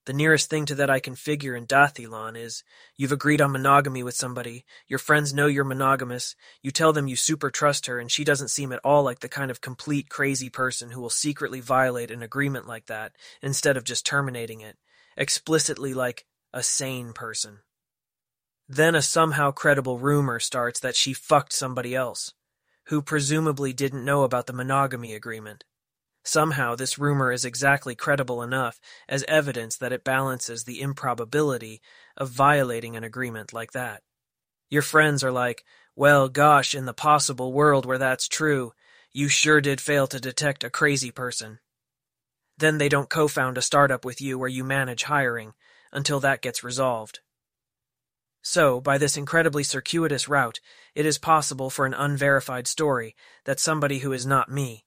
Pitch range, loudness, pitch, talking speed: 125-145 Hz, -24 LUFS, 135 Hz, 170 wpm